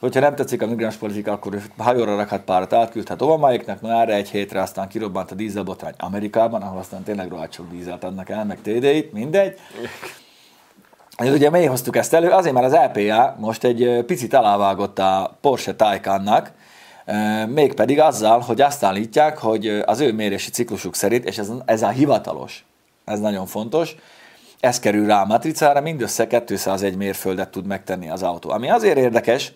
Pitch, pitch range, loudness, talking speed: 110 Hz, 100-125 Hz, -19 LUFS, 170 wpm